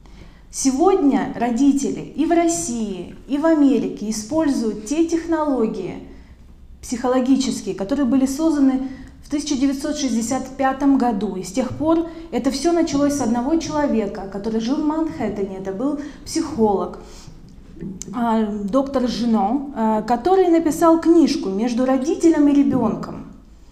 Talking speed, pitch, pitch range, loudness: 110 wpm, 265 Hz, 220-295 Hz, -20 LUFS